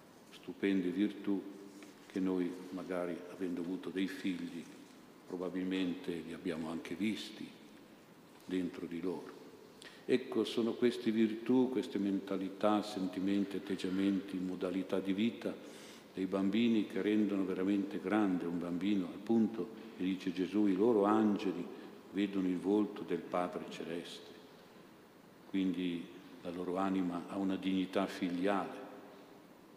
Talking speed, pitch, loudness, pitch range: 115 wpm, 95 Hz, -36 LUFS, 95-100 Hz